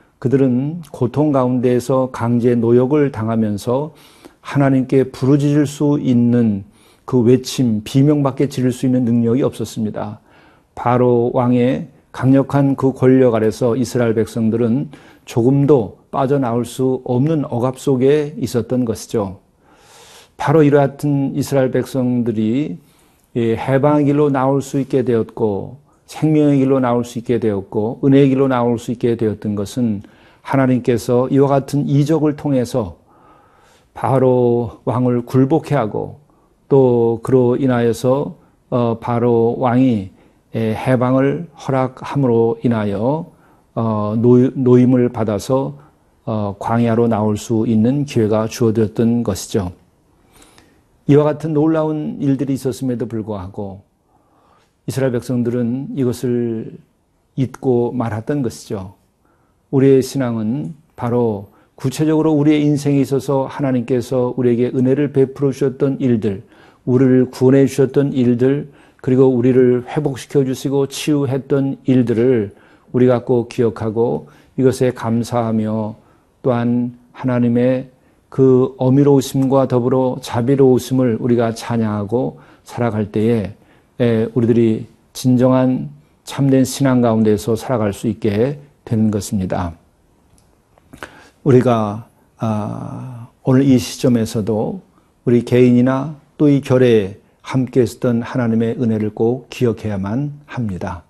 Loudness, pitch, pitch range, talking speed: -16 LUFS, 125 Hz, 115-135 Hz, 260 characters per minute